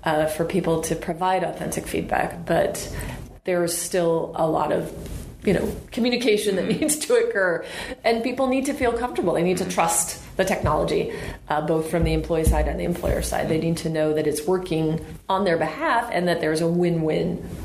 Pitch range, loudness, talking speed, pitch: 160-215 Hz, -23 LUFS, 195 wpm, 175 Hz